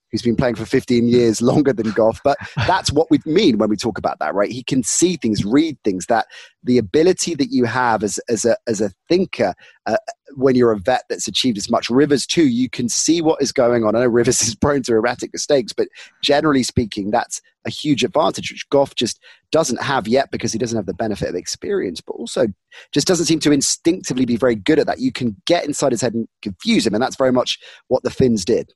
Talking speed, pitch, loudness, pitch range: 240 wpm, 130 Hz, -18 LUFS, 115-155 Hz